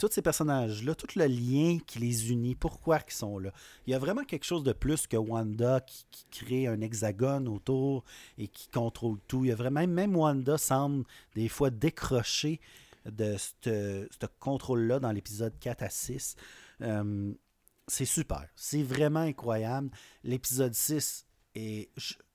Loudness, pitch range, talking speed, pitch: -32 LUFS, 110-145 Hz, 165 wpm, 125 Hz